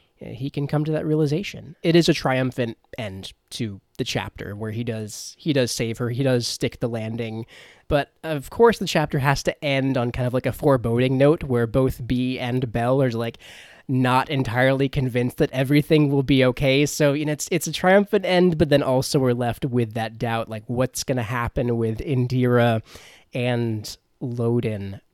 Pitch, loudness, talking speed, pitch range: 130 Hz, -22 LUFS, 195 wpm, 120-145 Hz